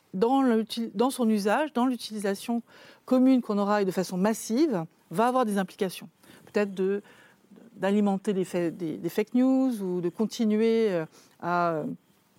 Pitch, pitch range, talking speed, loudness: 215 Hz, 190-235 Hz, 135 wpm, -27 LUFS